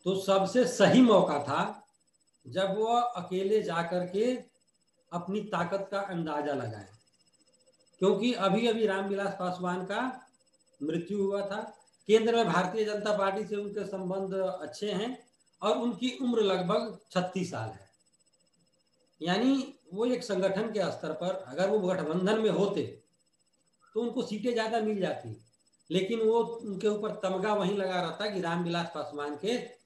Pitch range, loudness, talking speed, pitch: 180-220 Hz, -30 LUFS, 145 wpm, 200 Hz